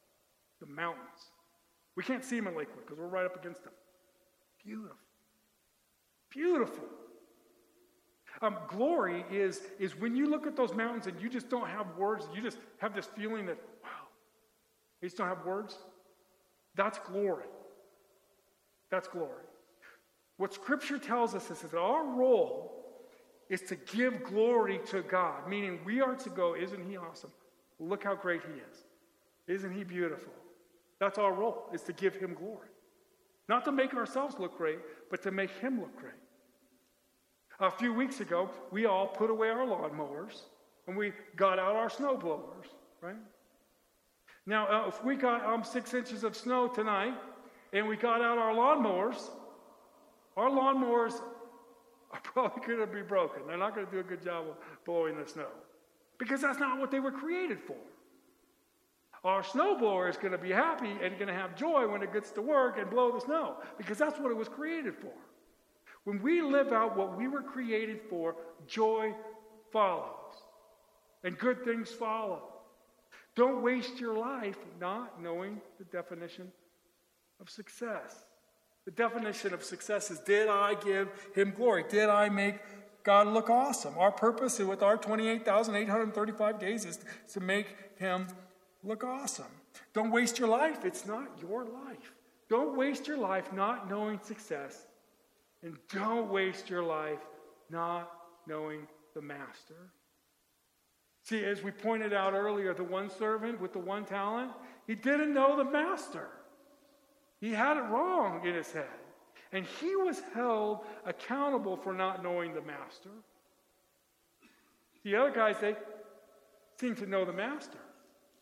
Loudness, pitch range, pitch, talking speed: -33 LUFS, 185-245 Hz, 210 Hz, 155 wpm